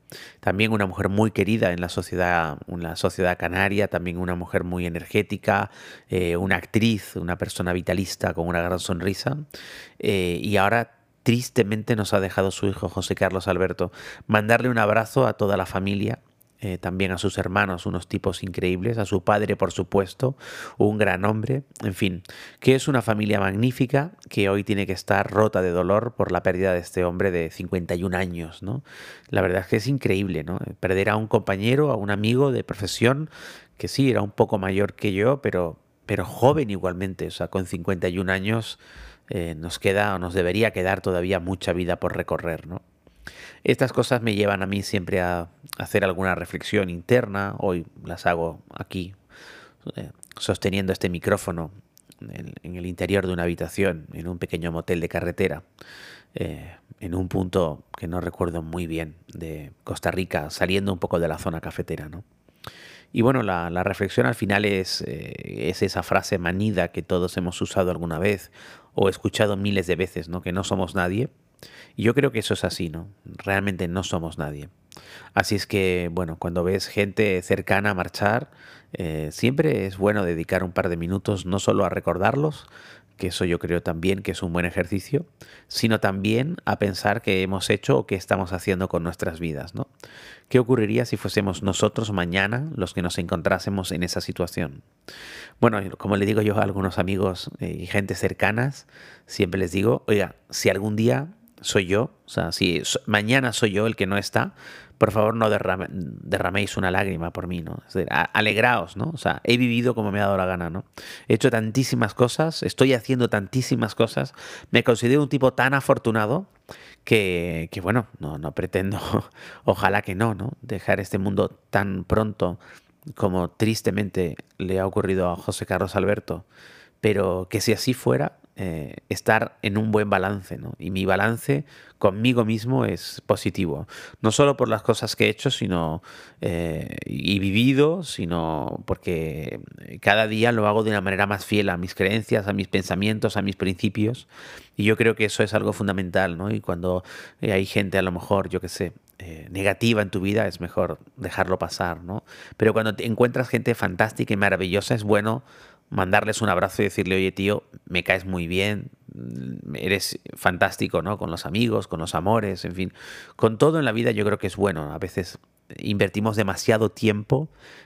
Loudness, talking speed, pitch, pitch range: -24 LUFS, 180 wpm, 100 Hz, 90-110 Hz